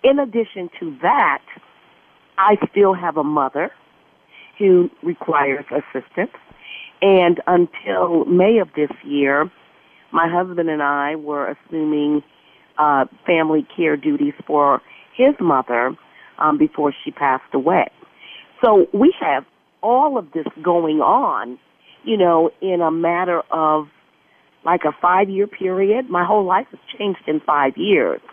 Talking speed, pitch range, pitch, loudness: 130 wpm, 155-200 Hz, 175 Hz, -18 LUFS